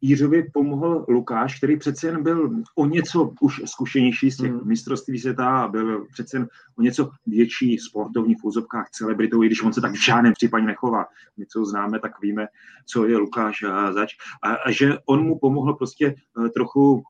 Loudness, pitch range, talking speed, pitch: -22 LUFS, 110-140 Hz, 185 wpm, 125 Hz